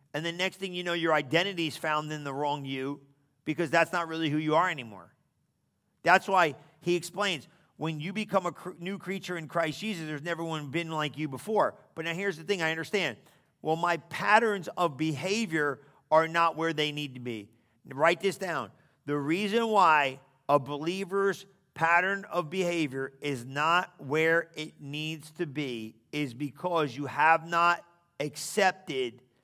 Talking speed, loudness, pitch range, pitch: 175 wpm, -29 LUFS, 145-180 Hz, 160 Hz